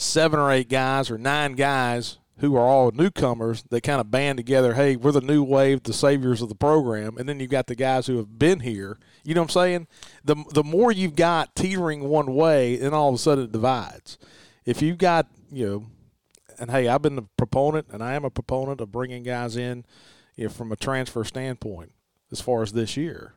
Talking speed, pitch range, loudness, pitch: 225 wpm, 120-150 Hz, -23 LUFS, 130 Hz